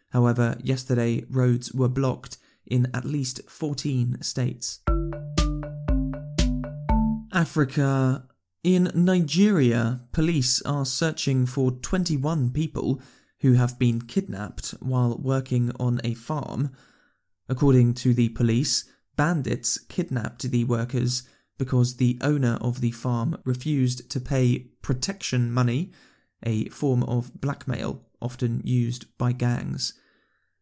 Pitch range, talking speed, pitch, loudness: 120-140 Hz, 110 wpm, 125 Hz, -25 LUFS